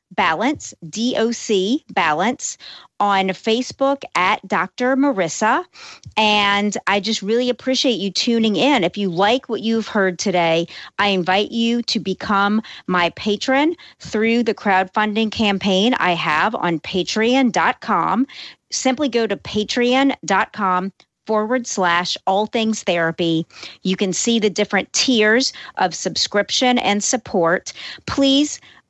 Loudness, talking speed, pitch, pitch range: -18 LUFS, 120 wpm, 215 Hz, 190-240 Hz